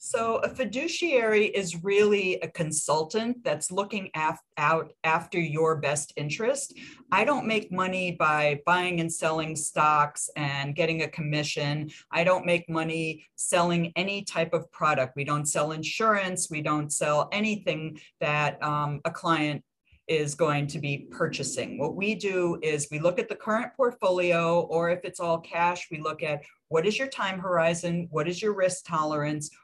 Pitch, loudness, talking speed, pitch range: 165 Hz, -27 LUFS, 165 wpm, 155-185 Hz